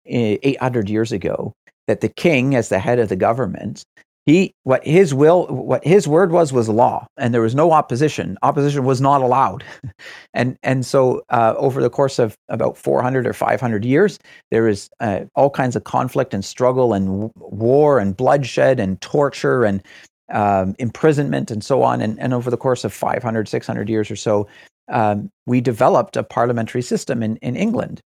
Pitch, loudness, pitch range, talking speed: 125 Hz, -18 LUFS, 110-135 Hz, 185 wpm